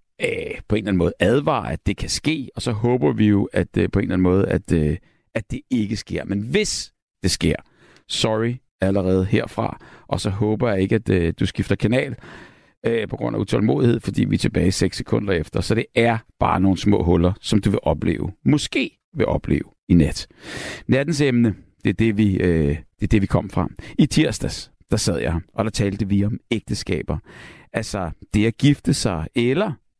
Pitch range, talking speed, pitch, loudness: 95-115 Hz, 210 wpm, 105 Hz, -21 LUFS